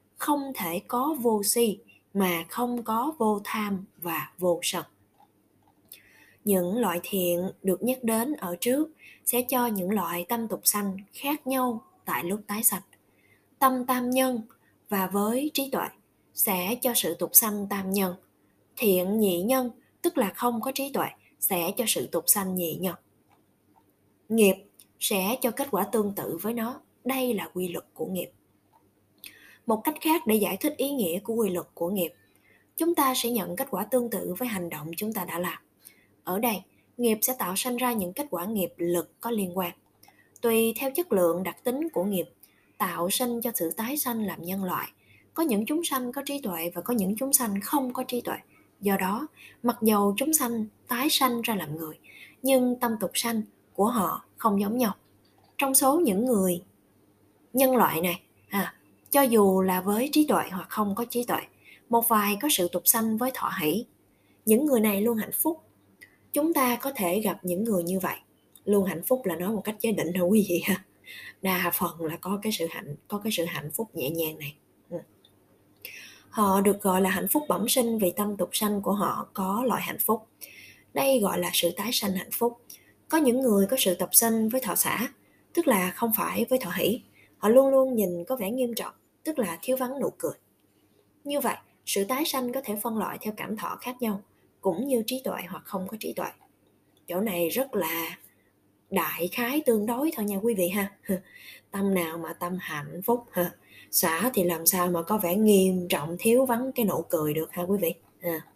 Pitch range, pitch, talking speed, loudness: 180-245 Hz, 210 Hz, 200 wpm, -27 LUFS